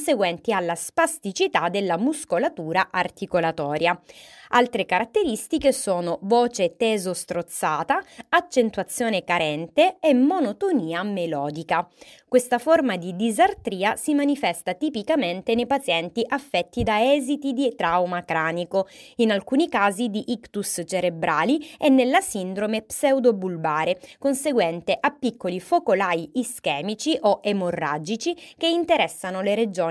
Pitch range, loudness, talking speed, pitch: 180-275 Hz, -23 LUFS, 100 wpm, 215 Hz